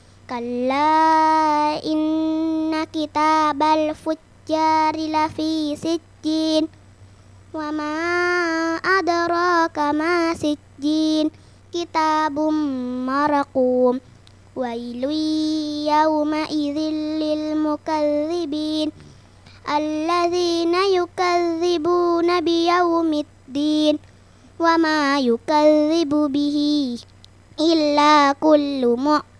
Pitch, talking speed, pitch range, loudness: 310 Hz, 50 wpm, 295-320 Hz, -20 LUFS